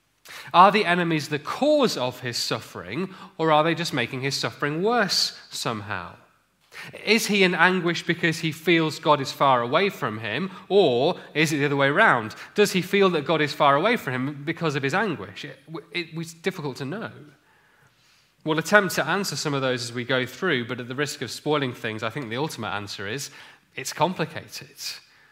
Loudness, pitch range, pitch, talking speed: -23 LUFS, 135-180 Hz, 155 Hz, 195 wpm